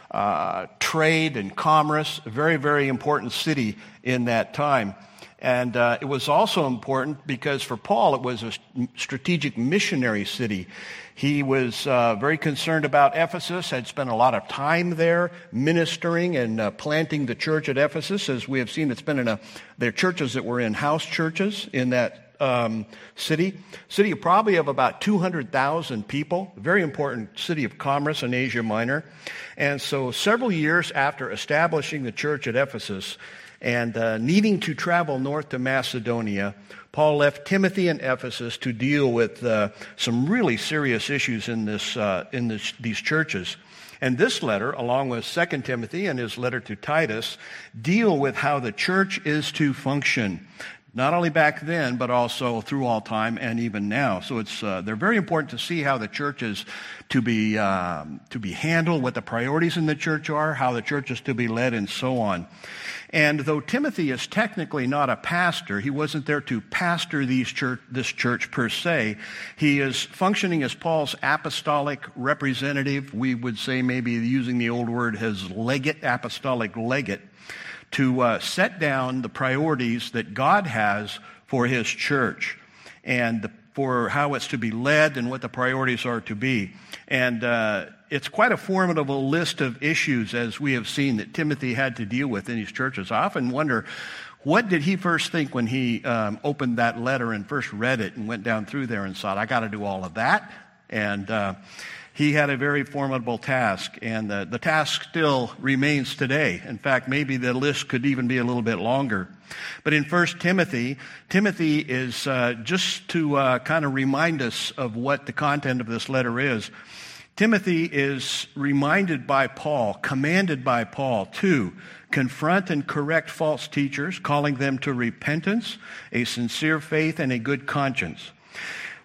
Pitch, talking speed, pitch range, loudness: 135 Hz, 180 wpm, 120-155 Hz, -24 LUFS